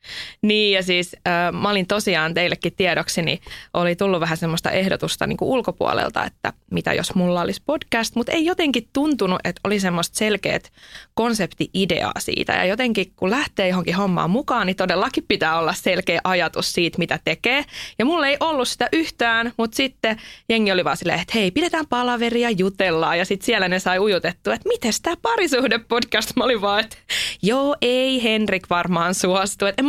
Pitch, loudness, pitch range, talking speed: 205 Hz, -20 LUFS, 180-245 Hz, 175 wpm